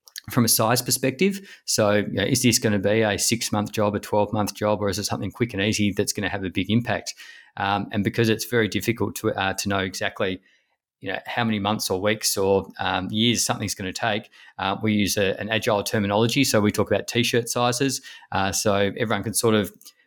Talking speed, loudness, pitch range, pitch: 235 wpm, -23 LUFS, 100-115 Hz, 105 Hz